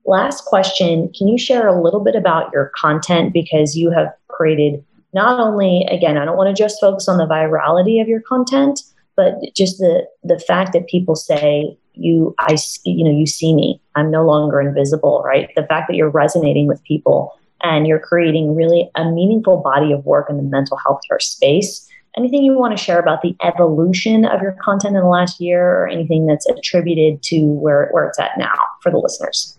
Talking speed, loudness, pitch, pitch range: 205 wpm, -15 LUFS, 170 Hz, 155-195 Hz